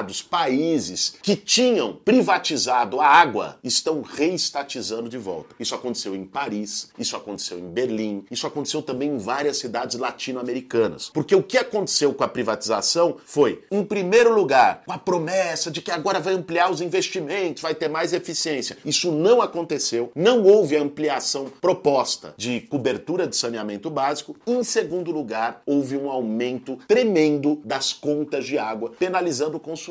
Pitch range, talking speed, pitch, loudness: 125-180 Hz, 155 wpm, 150 Hz, -22 LUFS